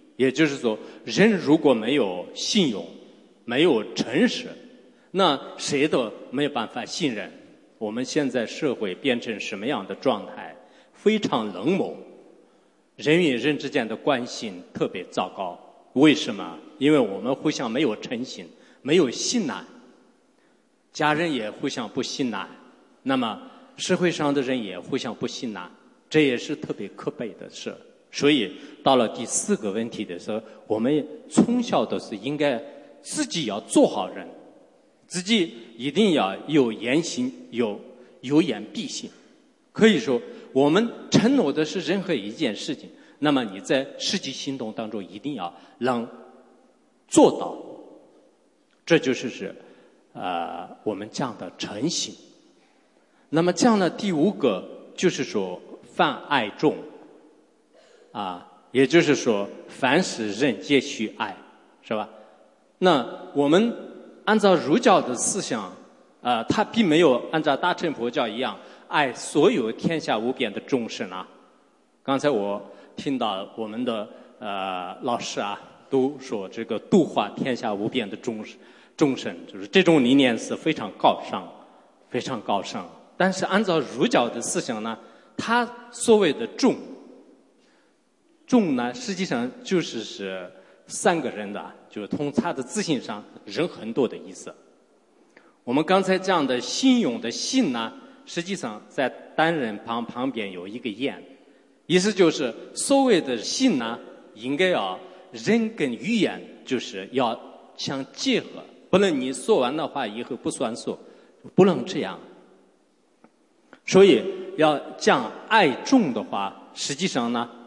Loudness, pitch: -24 LUFS, 175 Hz